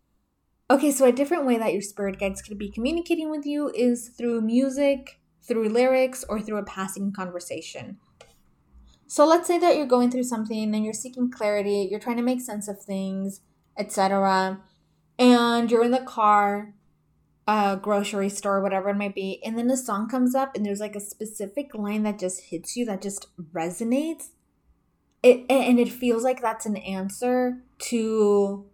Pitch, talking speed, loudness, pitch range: 215 Hz, 180 wpm, -24 LUFS, 200-250 Hz